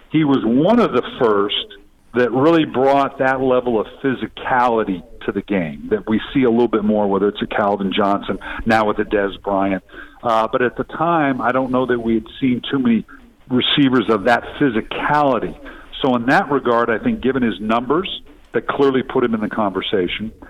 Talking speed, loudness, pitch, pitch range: 195 wpm, -18 LUFS, 120 Hz, 105-135 Hz